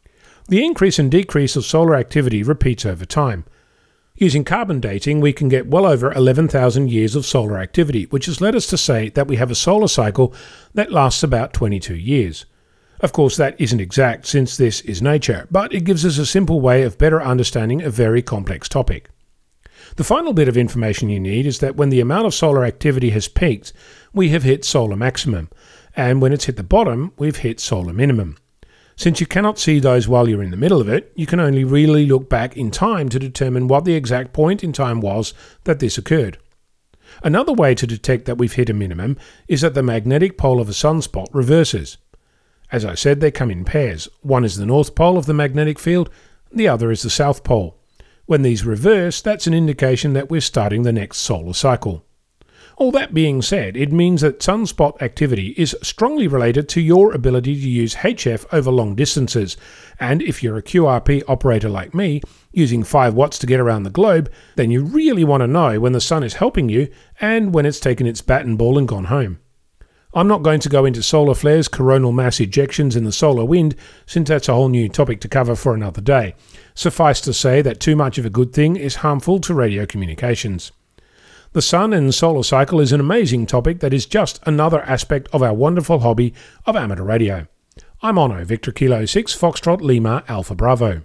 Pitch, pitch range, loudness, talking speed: 135 Hz, 115-155 Hz, -17 LUFS, 205 wpm